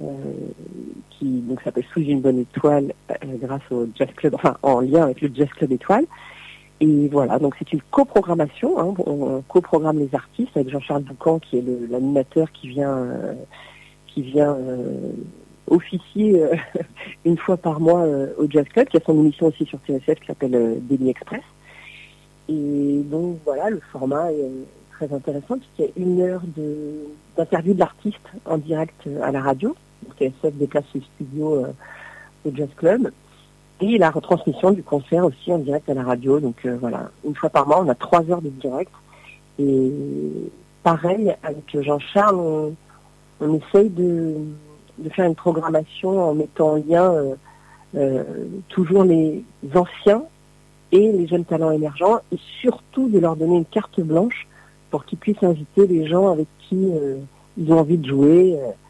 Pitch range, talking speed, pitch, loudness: 140-175 Hz, 175 wpm, 155 Hz, -20 LUFS